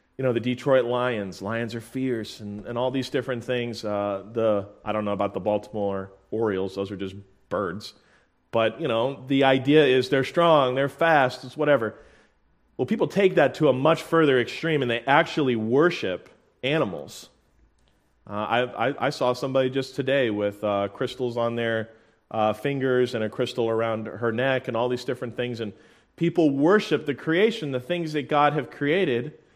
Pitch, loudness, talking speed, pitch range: 125 Hz, -24 LUFS, 185 wpm, 110-140 Hz